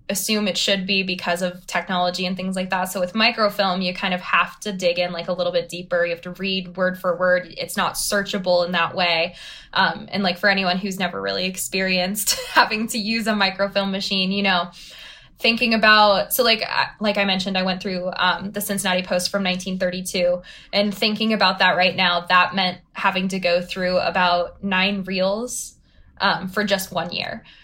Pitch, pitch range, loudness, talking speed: 185 Hz, 180-200 Hz, -20 LUFS, 200 wpm